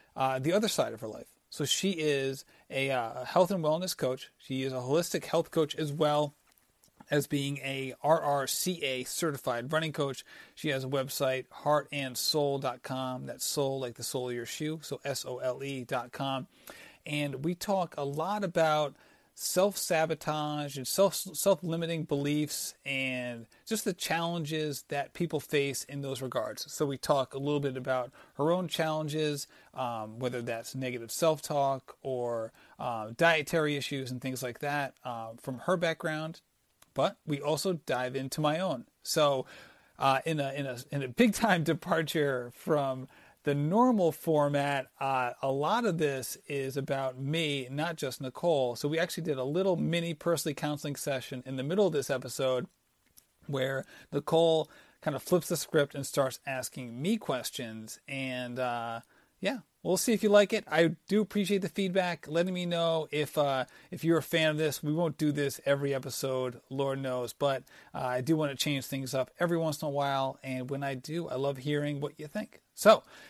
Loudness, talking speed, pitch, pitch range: -31 LUFS, 180 wpm, 145 Hz, 135-165 Hz